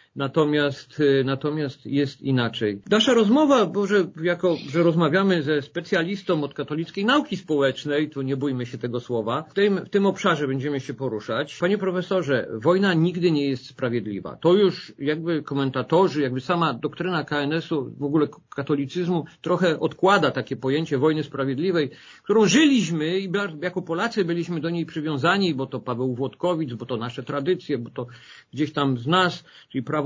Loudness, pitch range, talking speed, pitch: -23 LUFS, 135-180 Hz, 160 wpm, 155 Hz